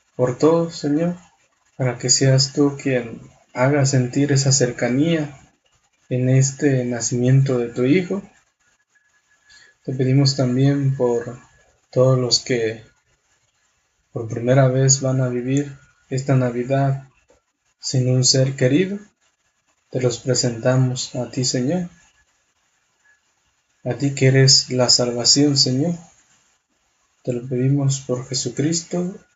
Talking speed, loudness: 110 wpm, -19 LUFS